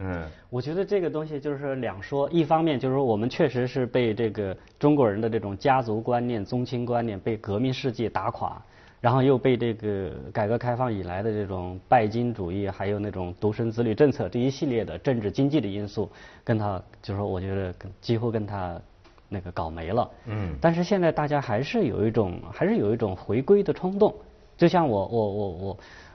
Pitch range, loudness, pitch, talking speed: 100-130 Hz, -26 LUFS, 115 Hz, 305 characters per minute